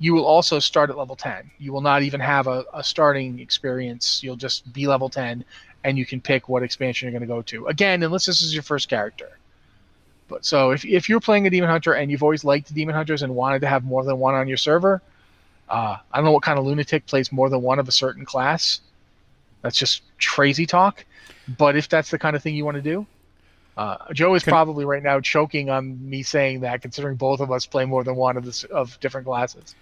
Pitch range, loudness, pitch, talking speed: 130-155 Hz, -21 LUFS, 140 Hz, 240 wpm